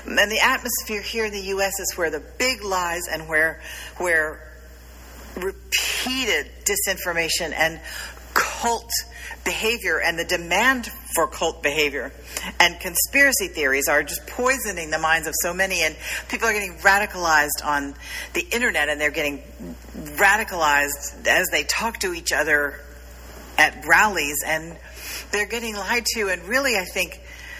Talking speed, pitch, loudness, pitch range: 145 wpm, 180 Hz, -21 LUFS, 155-210 Hz